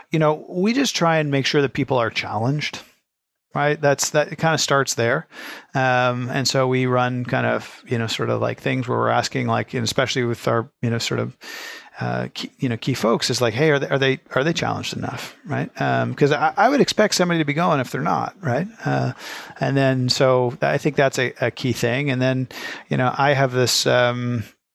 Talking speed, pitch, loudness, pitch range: 235 wpm, 130 Hz, -21 LUFS, 120-140 Hz